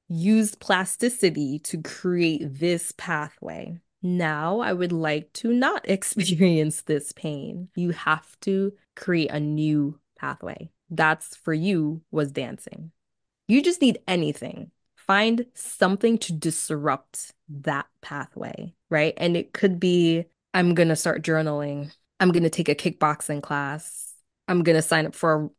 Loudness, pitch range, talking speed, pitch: -24 LUFS, 155-190 Hz, 145 wpm, 170 Hz